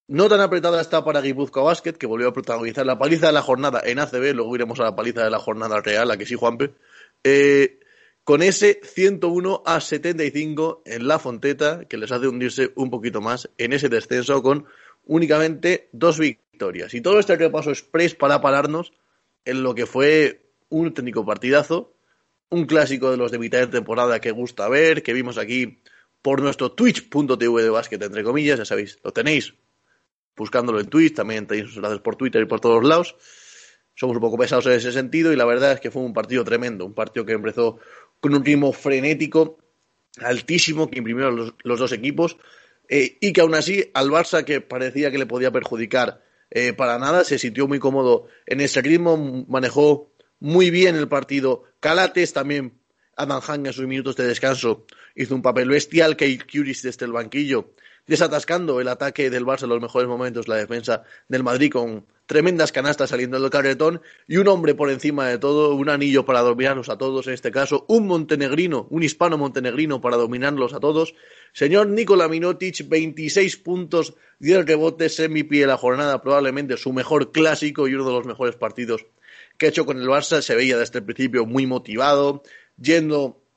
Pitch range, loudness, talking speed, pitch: 125-160 Hz, -20 LUFS, 190 wpm, 140 Hz